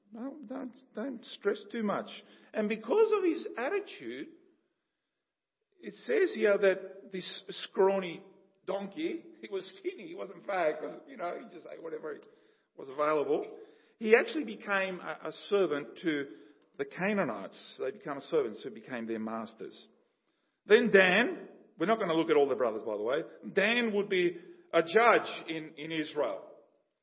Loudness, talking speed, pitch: -31 LUFS, 155 wpm, 235 Hz